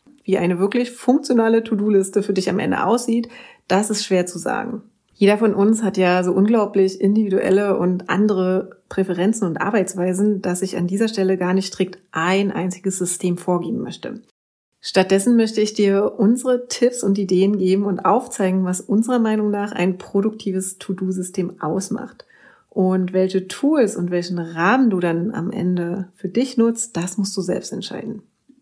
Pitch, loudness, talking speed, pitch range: 195 Hz, -19 LUFS, 165 wpm, 185-220 Hz